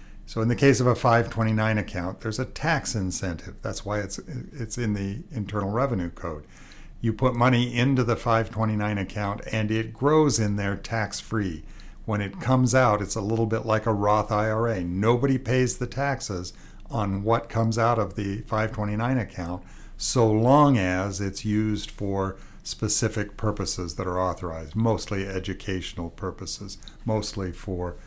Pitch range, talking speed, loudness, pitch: 100-115 Hz, 160 wpm, -25 LUFS, 110 Hz